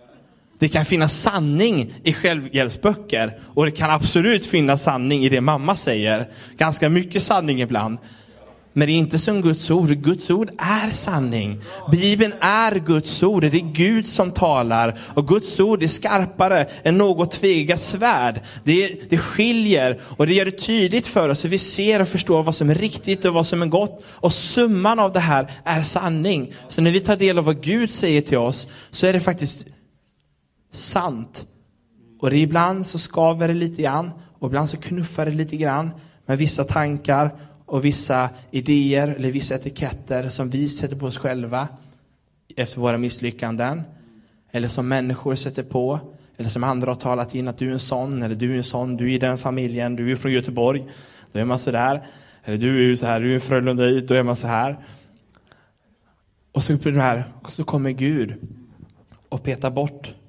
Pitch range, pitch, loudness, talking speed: 125-170 Hz, 145 Hz, -20 LUFS, 180 wpm